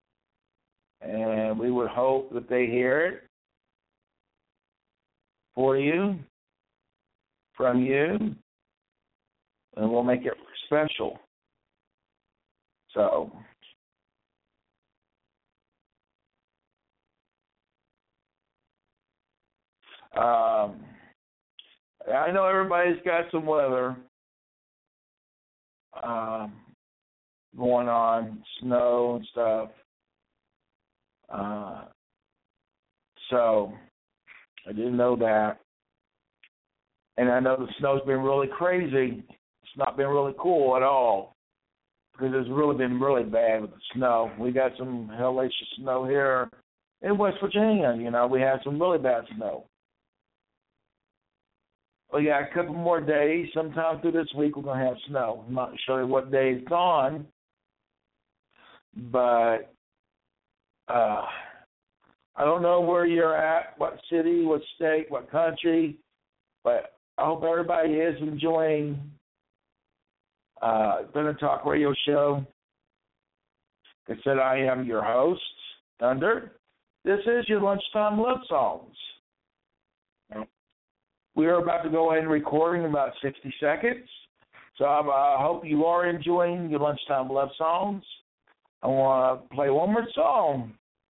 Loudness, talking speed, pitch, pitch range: -26 LUFS, 110 wpm, 140 Hz, 125-165 Hz